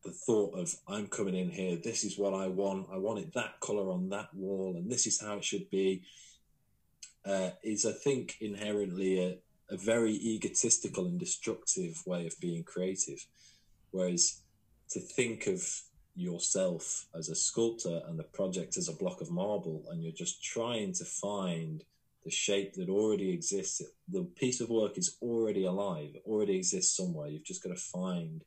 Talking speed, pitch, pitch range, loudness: 180 wpm, 100 Hz, 90-115 Hz, -34 LUFS